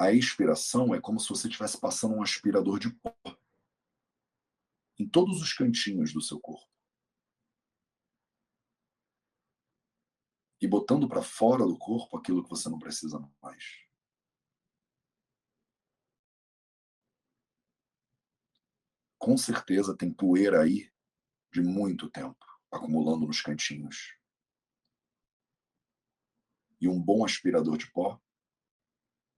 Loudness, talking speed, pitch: -29 LUFS, 100 wpm, 90 Hz